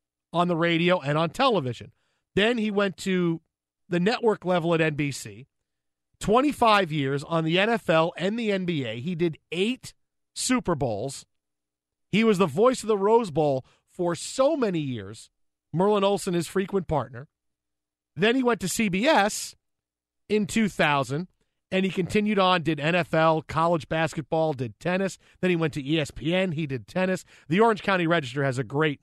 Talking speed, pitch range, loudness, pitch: 160 wpm, 140-195 Hz, -25 LUFS, 170 Hz